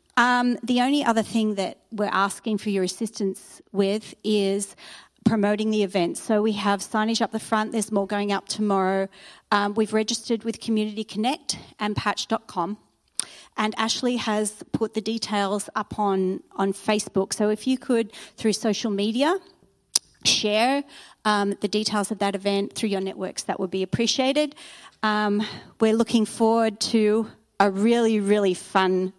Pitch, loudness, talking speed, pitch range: 215 Hz, -24 LUFS, 160 wpm, 200-225 Hz